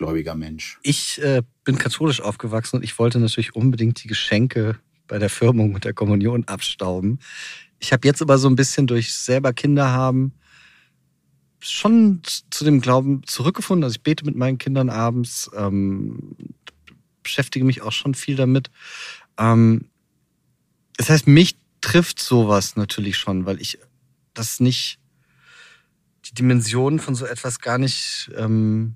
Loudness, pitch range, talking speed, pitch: -20 LUFS, 110-135 Hz, 145 wpm, 125 Hz